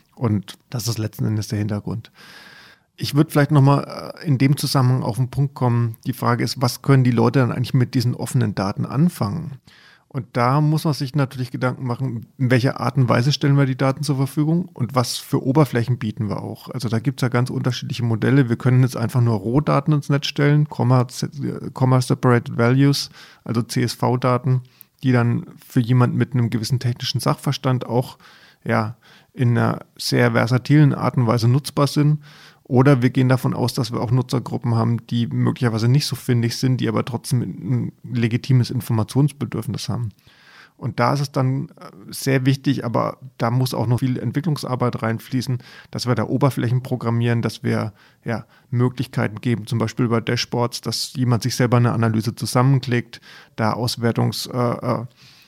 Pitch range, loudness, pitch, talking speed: 120-140 Hz, -20 LUFS, 125 Hz, 175 wpm